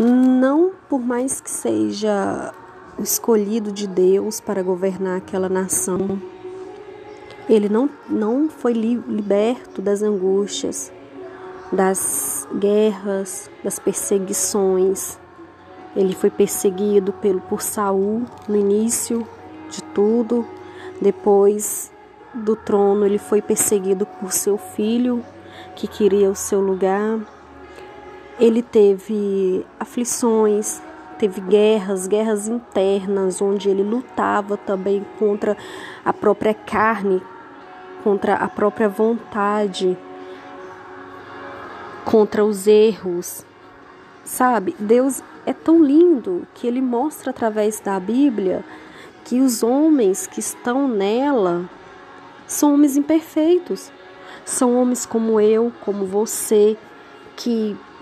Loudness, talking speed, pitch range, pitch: -19 LUFS, 100 wpm, 195-245 Hz, 210 Hz